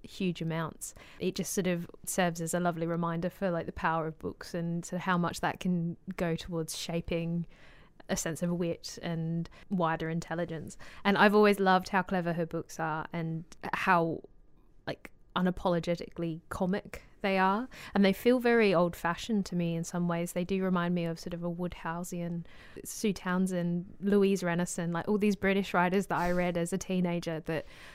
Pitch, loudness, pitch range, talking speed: 175 Hz, -31 LUFS, 170-190 Hz, 180 wpm